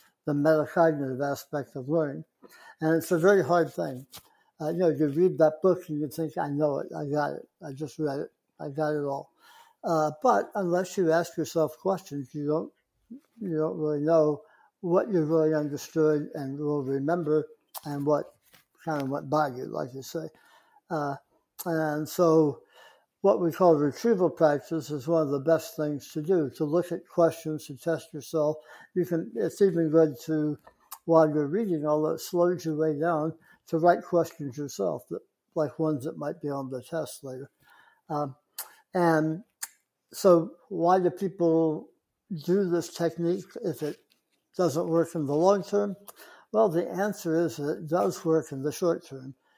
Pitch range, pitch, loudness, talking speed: 150-175 Hz, 160 Hz, -27 LUFS, 175 wpm